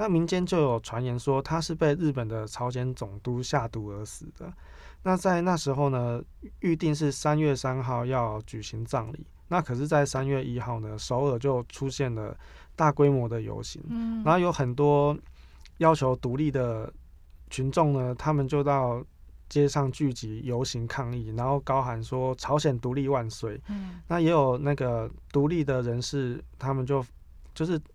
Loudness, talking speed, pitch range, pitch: -28 LUFS, 245 characters per minute, 120-150 Hz, 135 Hz